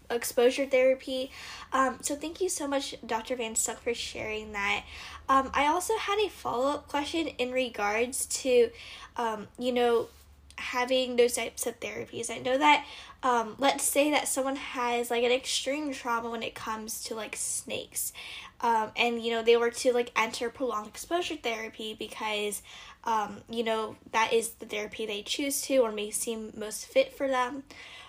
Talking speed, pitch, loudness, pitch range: 175 wpm, 245 Hz, -29 LUFS, 230-270 Hz